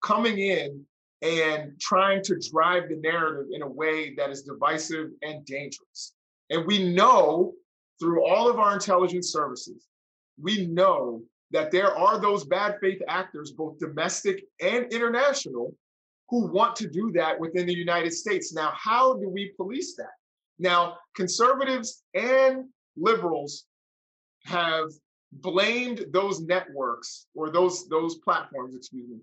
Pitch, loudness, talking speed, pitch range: 180 Hz, -25 LUFS, 140 wpm, 160-210 Hz